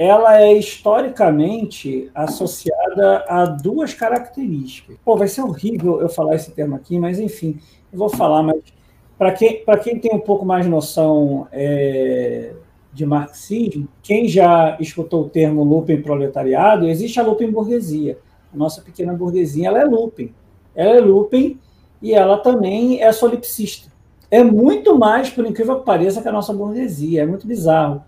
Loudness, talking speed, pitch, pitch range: -16 LUFS, 155 wpm, 185 Hz, 155-220 Hz